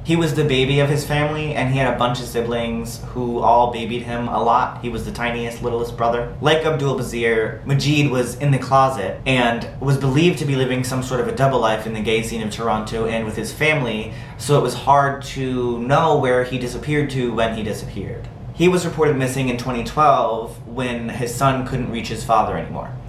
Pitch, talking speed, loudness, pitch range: 125 Hz, 215 wpm, -19 LUFS, 115-140 Hz